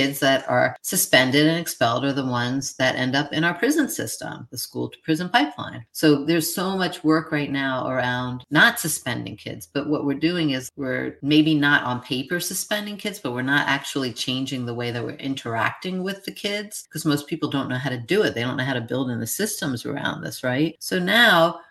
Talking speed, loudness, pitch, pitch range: 220 wpm, -22 LUFS, 145 Hz, 130-170 Hz